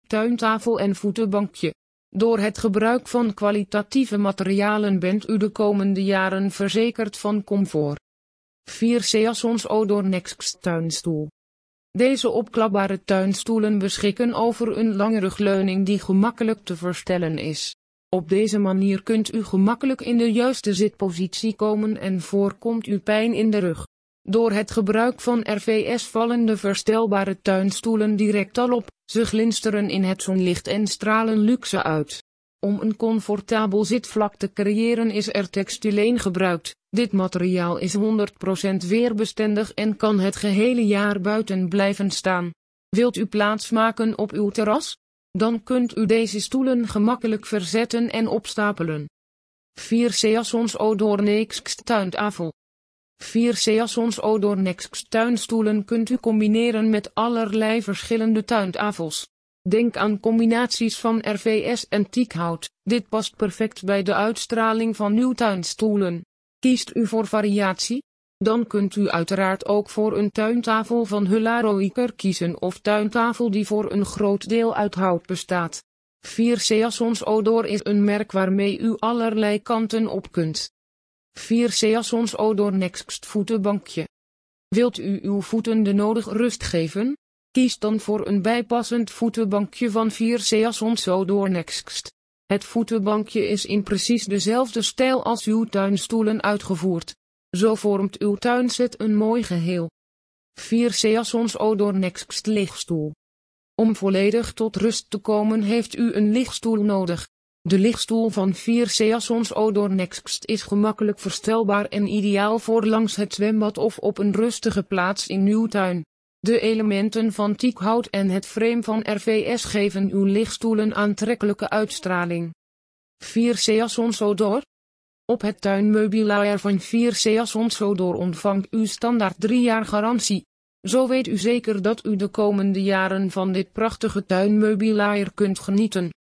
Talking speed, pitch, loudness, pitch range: 135 wpm, 210 Hz, -22 LUFS, 195-225 Hz